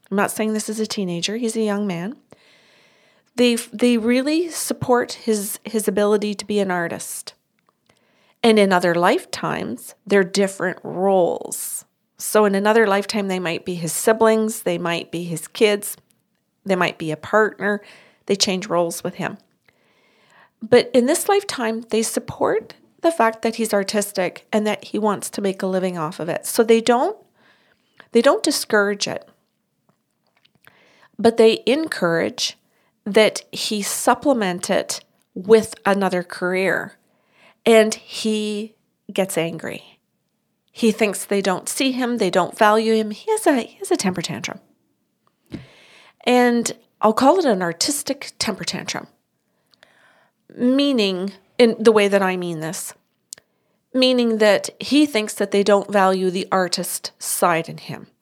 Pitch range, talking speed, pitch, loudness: 190-230 Hz, 145 wpm, 210 Hz, -20 LUFS